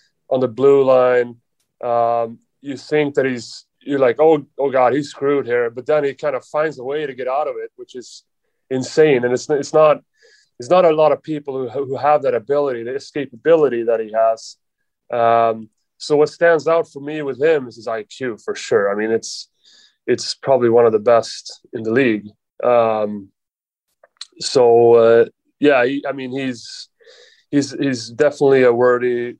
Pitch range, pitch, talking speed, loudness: 120-155 Hz, 135 Hz, 185 wpm, -17 LUFS